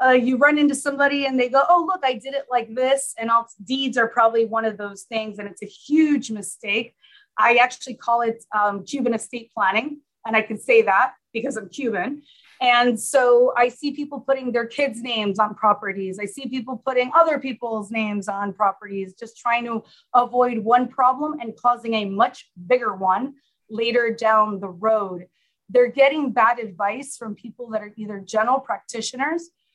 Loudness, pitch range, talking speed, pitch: -21 LUFS, 215-265 Hz, 185 wpm, 235 Hz